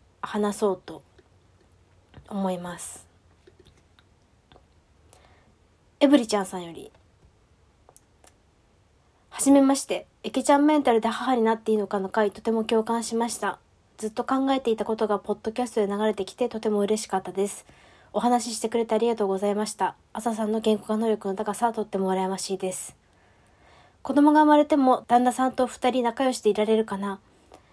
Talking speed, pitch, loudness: 335 characters per minute, 210 Hz, -24 LUFS